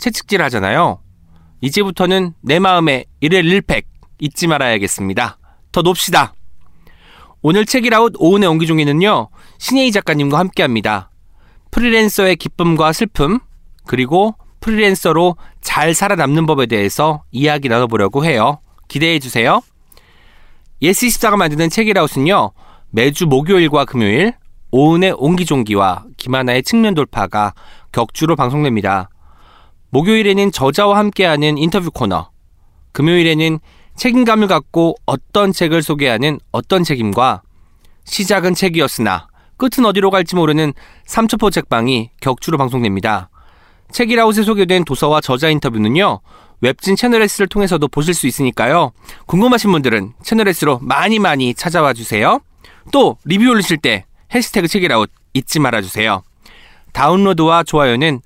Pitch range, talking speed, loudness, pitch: 115-195 Hz, 320 characters per minute, -14 LUFS, 155 Hz